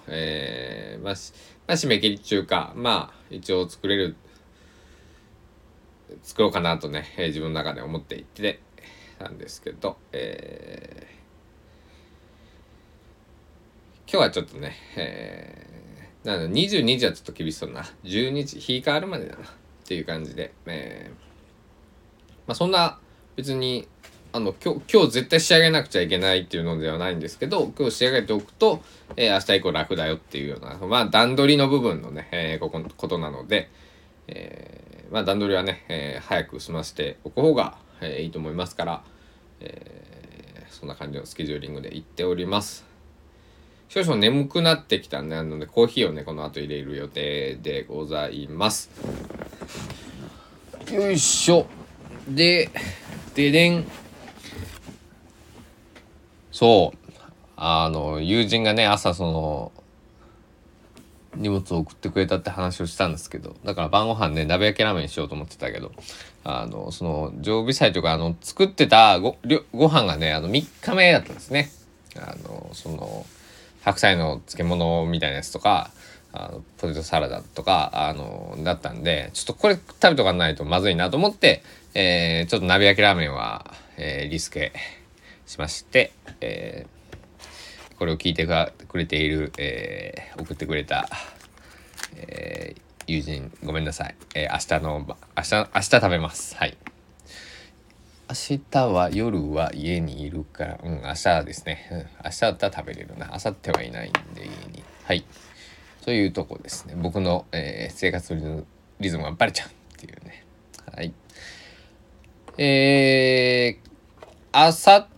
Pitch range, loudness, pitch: 80-115 Hz, -23 LUFS, 90 Hz